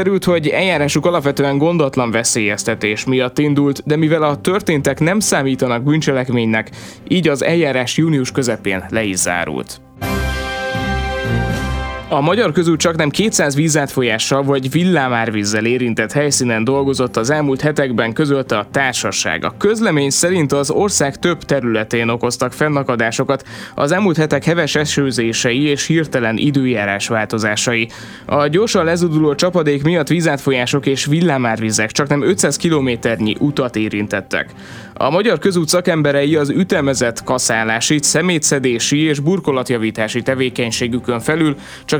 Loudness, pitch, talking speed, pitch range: -16 LUFS, 140 Hz, 120 wpm, 115-155 Hz